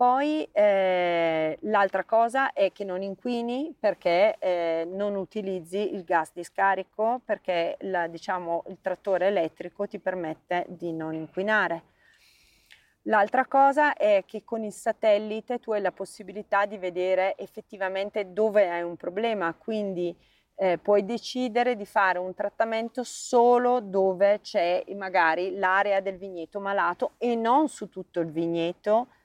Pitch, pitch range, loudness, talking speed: 200 Hz, 180-225 Hz, -26 LUFS, 135 wpm